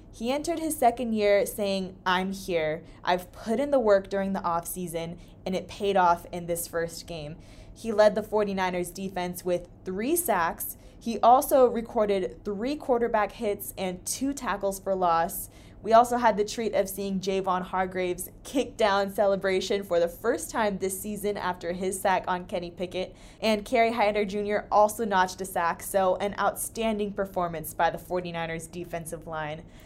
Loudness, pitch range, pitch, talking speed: -27 LUFS, 180-215 Hz, 195 Hz, 170 wpm